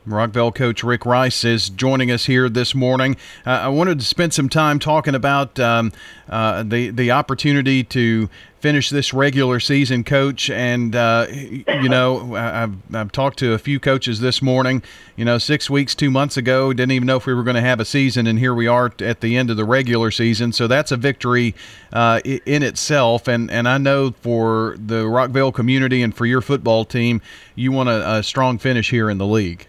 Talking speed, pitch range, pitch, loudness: 205 wpm, 115-135 Hz, 125 Hz, -17 LUFS